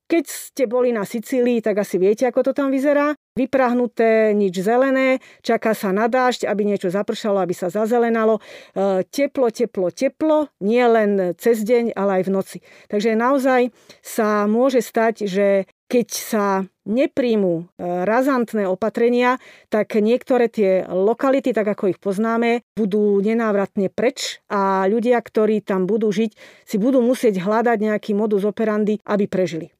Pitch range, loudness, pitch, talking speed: 200-245 Hz, -19 LUFS, 220 Hz, 145 wpm